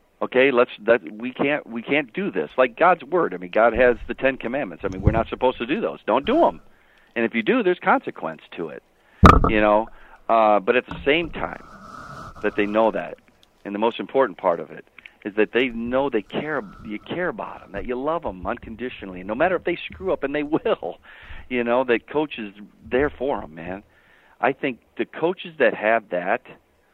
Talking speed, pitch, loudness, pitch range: 215 wpm, 115 Hz, -22 LUFS, 105-130 Hz